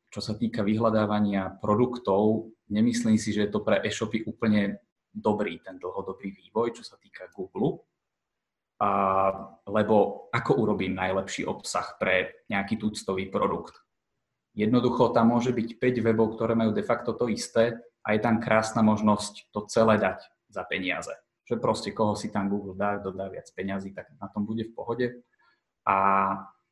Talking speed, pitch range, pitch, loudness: 155 wpm, 95-110 Hz, 105 Hz, -27 LUFS